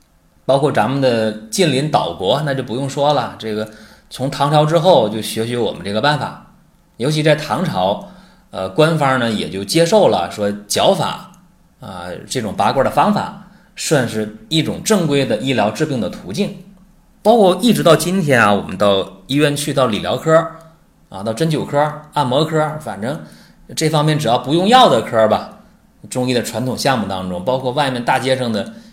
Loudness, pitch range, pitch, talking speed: -16 LUFS, 110-160 Hz, 140 Hz, 265 characters per minute